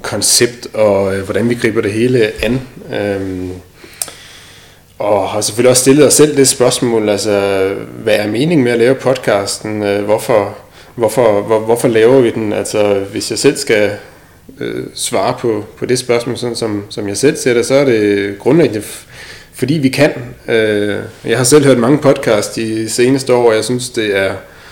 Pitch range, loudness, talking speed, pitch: 100-125 Hz, -13 LUFS, 180 wpm, 115 Hz